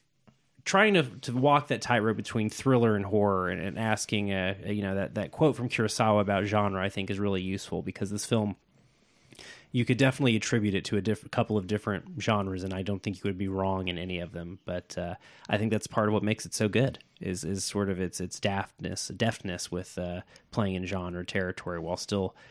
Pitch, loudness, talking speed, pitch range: 105 Hz, -29 LUFS, 225 wpm, 95-115 Hz